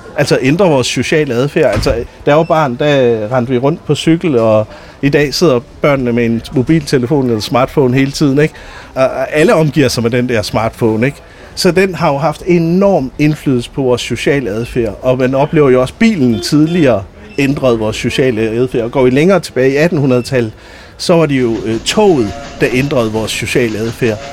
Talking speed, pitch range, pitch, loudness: 190 wpm, 120-150 Hz, 130 Hz, -12 LUFS